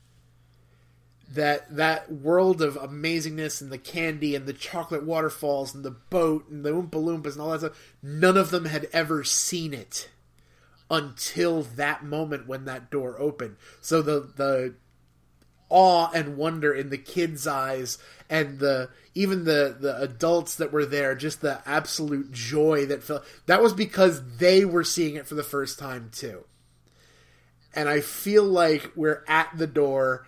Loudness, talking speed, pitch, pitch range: -25 LUFS, 165 wpm, 150 Hz, 130-160 Hz